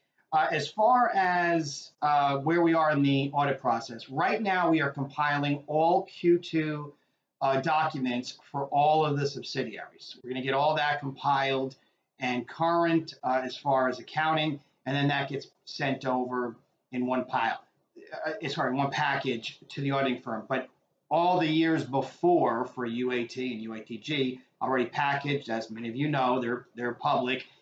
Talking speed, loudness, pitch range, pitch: 165 wpm, -28 LUFS, 130-155 Hz, 140 Hz